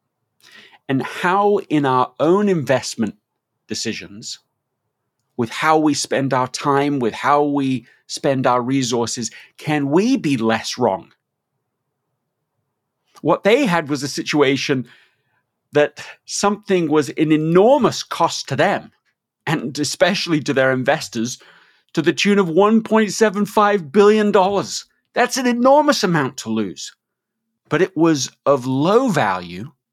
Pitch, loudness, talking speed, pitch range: 145 Hz, -18 LUFS, 120 wpm, 130-190 Hz